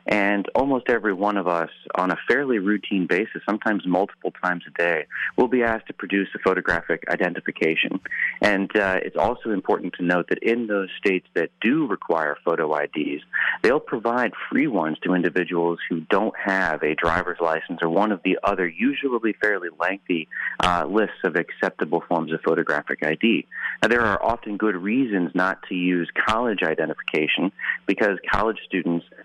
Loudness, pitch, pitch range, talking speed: -23 LUFS, 100 Hz, 90-110 Hz, 170 wpm